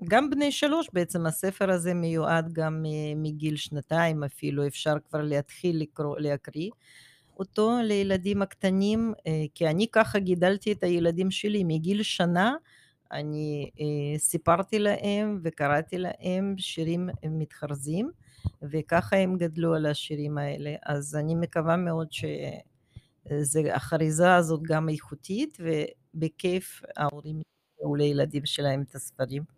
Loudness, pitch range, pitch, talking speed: -28 LUFS, 150-190 Hz, 160 Hz, 115 wpm